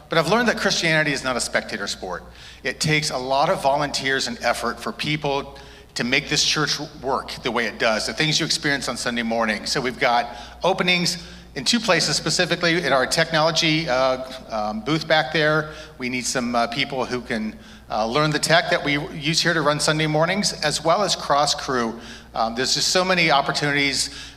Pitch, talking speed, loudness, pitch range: 145 Hz, 200 wpm, -21 LUFS, 130-165 Hz